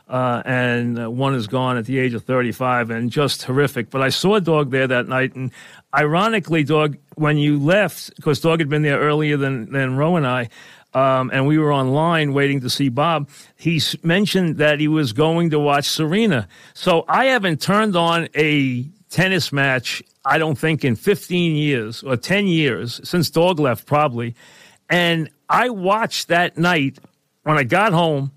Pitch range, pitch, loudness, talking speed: 130-170 Hz, 150 Hz, -18 LUFS, 180 wpm